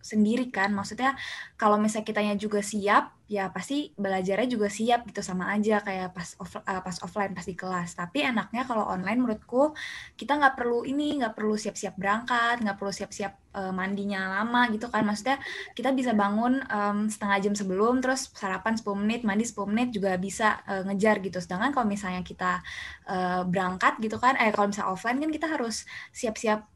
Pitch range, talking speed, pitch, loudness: 195-240 Hz, 180 wpm, 210 Hz, -28 LUFS